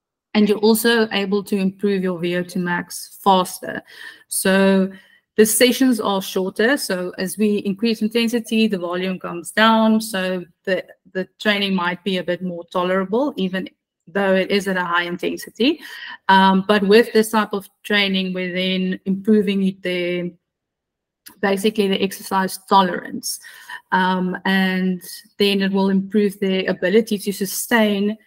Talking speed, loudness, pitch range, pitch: 140 wpm, -19 LUFS, 185-215 Hz, 195 Hz